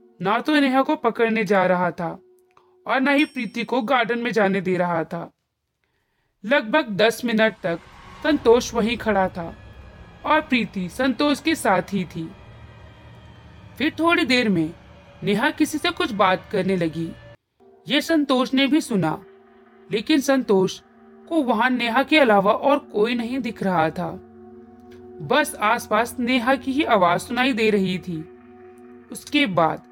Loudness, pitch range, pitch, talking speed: -21 LUFS, 170-265 Hz, 215 Hz, 150 wpm